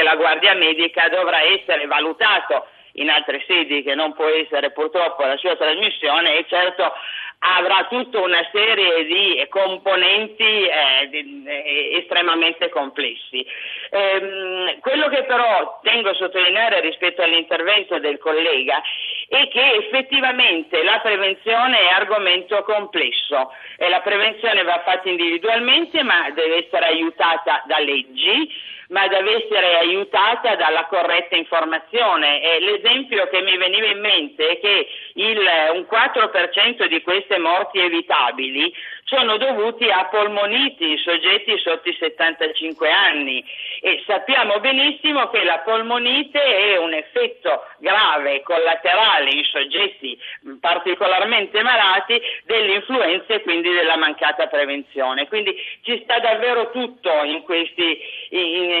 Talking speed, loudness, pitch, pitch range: 120 wpm, -17 LUFS, 185 Hz, 160-220 Hz